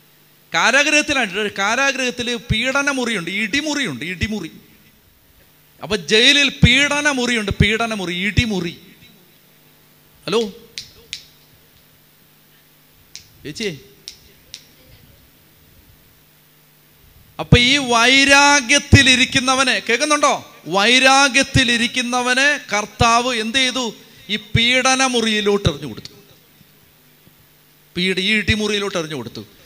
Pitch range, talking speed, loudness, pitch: 210-270 Hz, 65 wpm, -15 LUFS, 240 Hz